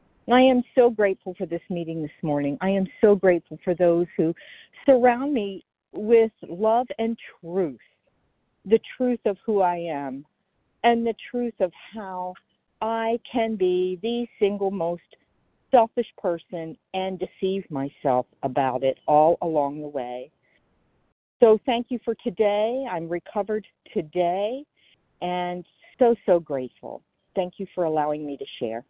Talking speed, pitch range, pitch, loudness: 145 wpm, 170-225 Hz, 190 Hz, -24 LUFS